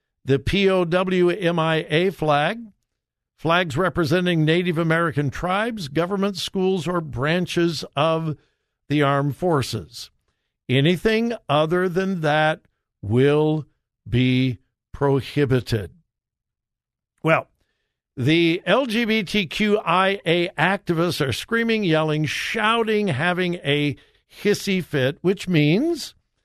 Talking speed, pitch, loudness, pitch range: 85 wpm, 170 Hz, -21 LUFS, 145-190 Hz